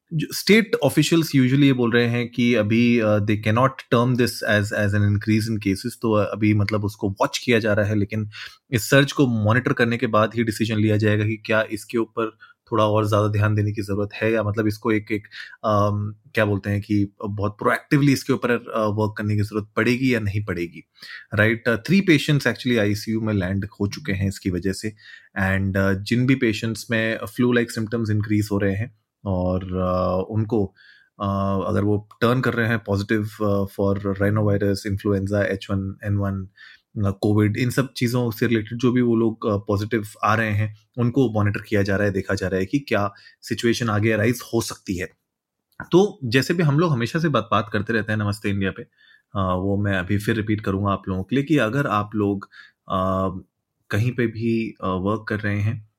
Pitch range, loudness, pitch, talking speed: 100-120 Hz, -22 LUFS, 105 Hz, 200 wpm